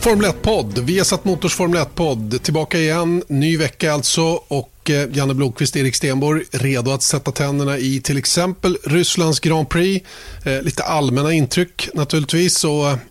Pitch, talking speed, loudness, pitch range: 155 Hz, 150 wpm, -17 LUFS, 140-175 Hz